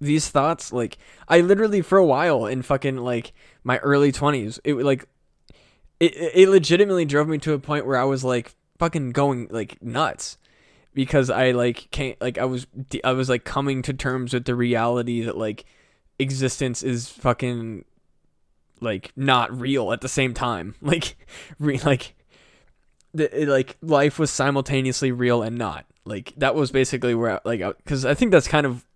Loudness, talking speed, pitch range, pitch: -22 LUFS, 180 wpm, 125-145 Hz, 130 Hz